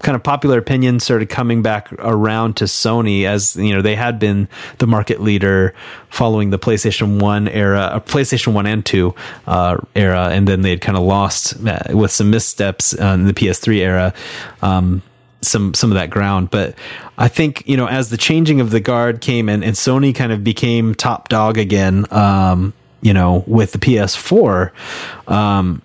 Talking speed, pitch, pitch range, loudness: 190 wpm, 105 Hz, 95-115 Hz, -15 LUFS